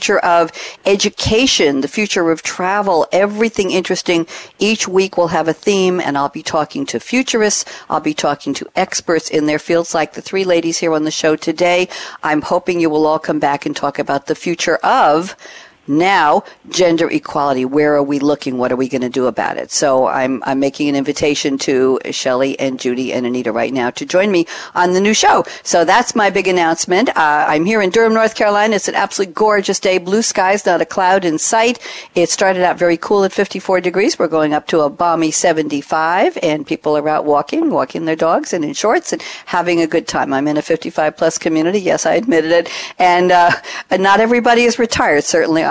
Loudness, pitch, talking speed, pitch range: -15 LUFS, 165 Hz, 210 wpm, 150-190 Hz